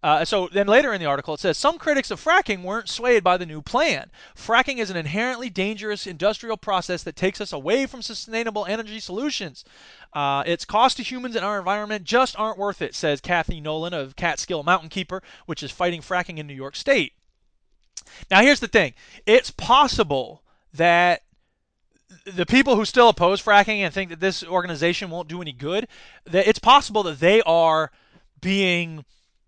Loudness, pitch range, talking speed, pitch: -21 LUFS, 170-225 Hz, 185 wpm, 190 Hz